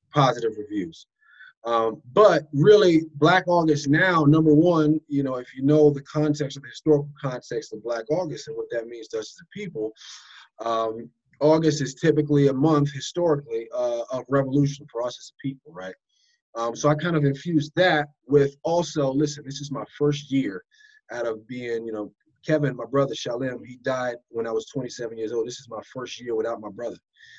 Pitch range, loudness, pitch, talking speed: 130-170 Hz, -23 LUFS, 145 Hz, 195 wpm